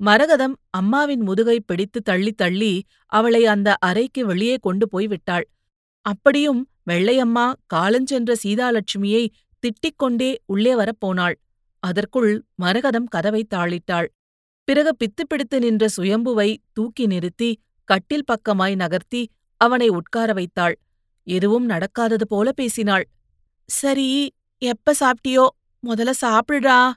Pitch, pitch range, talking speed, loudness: 225 Hz, 195-250 Hz, 100 wpm, -20 LUFS